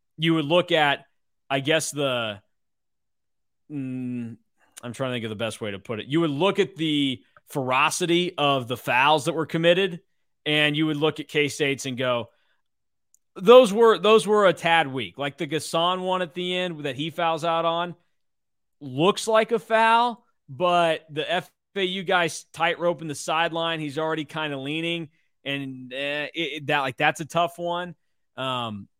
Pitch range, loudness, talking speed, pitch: 140-175 Hz, -23 LUFS, 180 wpm, 160 Hz